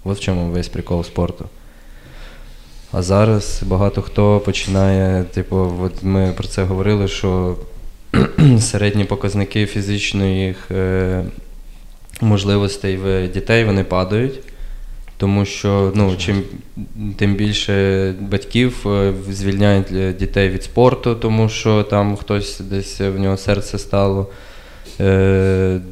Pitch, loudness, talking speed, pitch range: 100 Hz, -17 LUFS, 110 wpm, 95-105 Hz